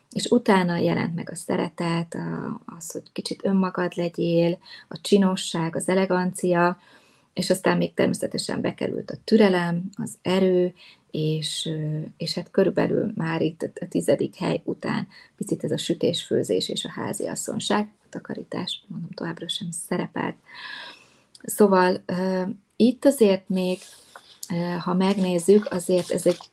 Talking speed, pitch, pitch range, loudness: 130 wpm, 180 Hz, 175-195 Hz, -24 LUFS